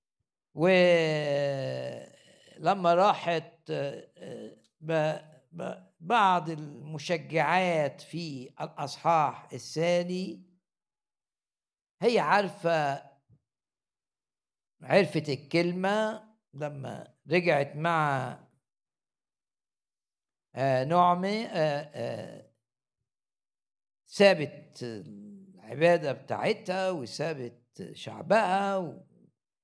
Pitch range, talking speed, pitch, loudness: 140-180 Hz, 45 wpm, 160 Hz, -28 LUFS